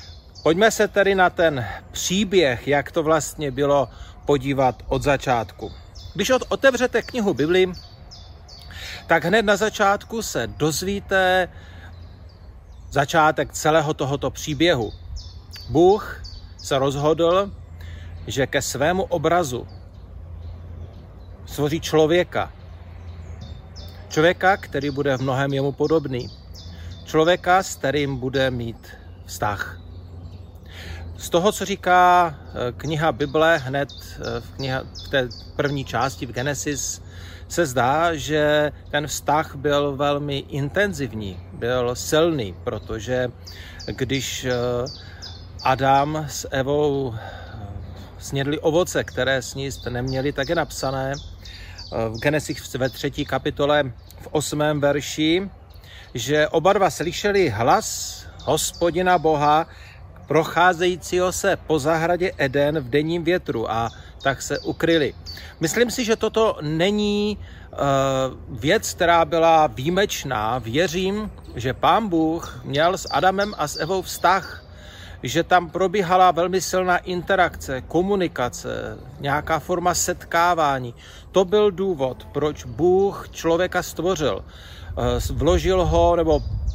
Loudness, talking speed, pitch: -21 LUFS, 110 wpm, 140 Hz